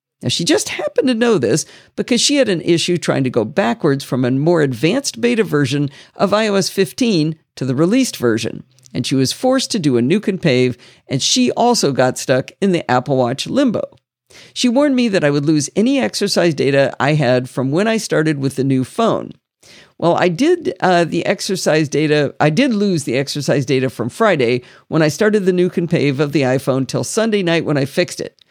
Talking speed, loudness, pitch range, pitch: 215 wpm, -16 LUFS, 135-205 Hz, 155 Hz